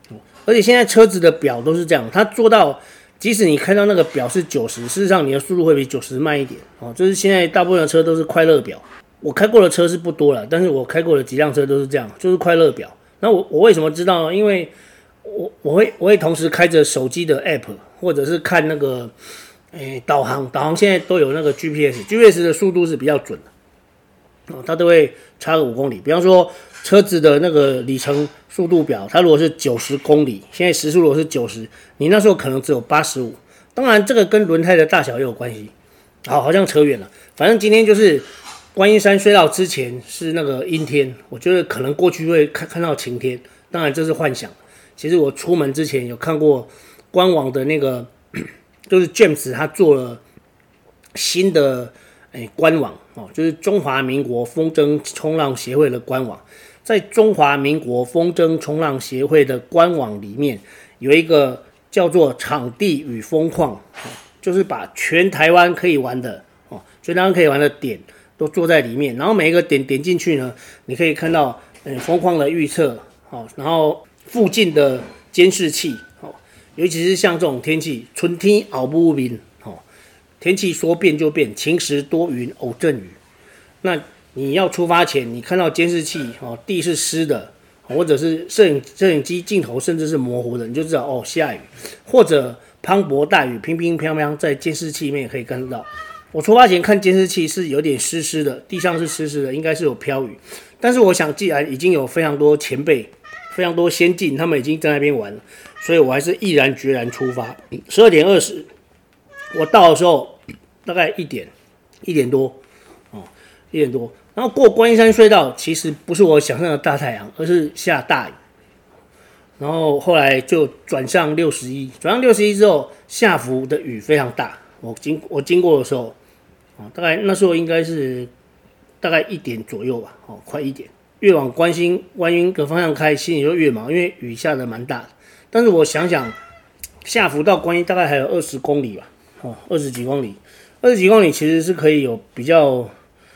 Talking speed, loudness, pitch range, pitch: 290 characters per minute, -16 LUFS, 140-180 Hz, 160 Hz